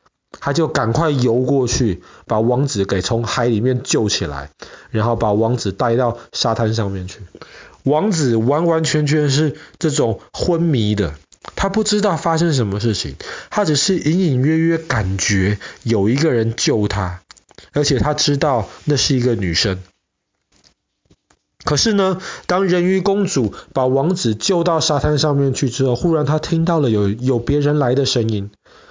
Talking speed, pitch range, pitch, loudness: 230 characters per minute, 110-155 Hz, 130 Hz, -17 LUFS